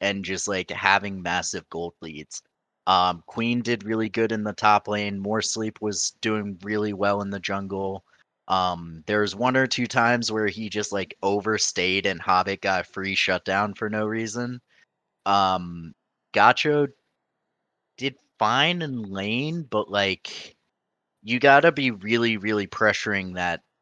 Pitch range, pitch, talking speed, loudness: 95-115 Hz, 105 Hz, 150 wpm, -24 LUFS